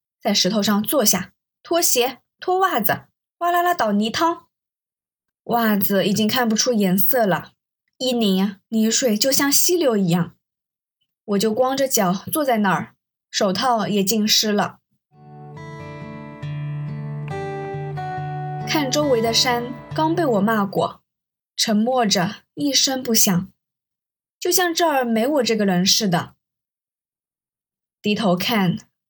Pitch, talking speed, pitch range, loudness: 215 Hz, 170 characters per minute, 180-250 Hz, -19 LUFS